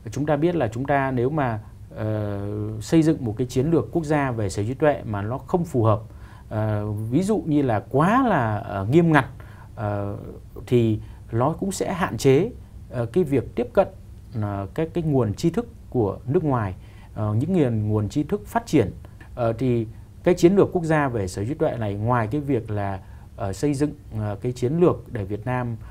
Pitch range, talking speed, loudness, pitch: 105-145 Hz, 205 wpm, -23 LUFS, 115 Hz